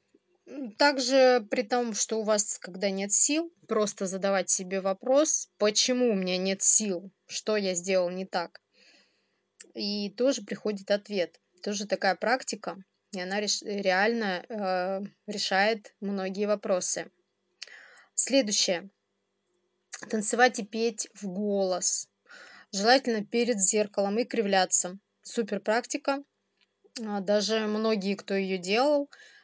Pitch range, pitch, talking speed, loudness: 195-240 Hz, 210 Hz, 110 wpm, -27 LUFS